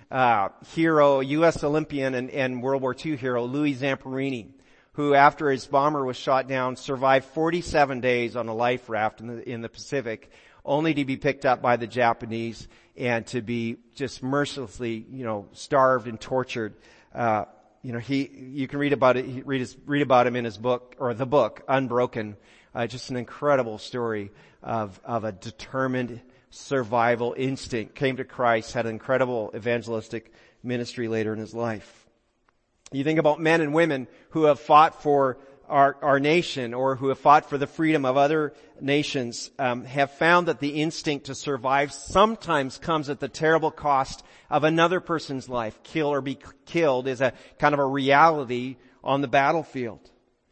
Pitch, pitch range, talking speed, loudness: 130 Hz, 120-145 Hz, 175 wpm, -24 LUFS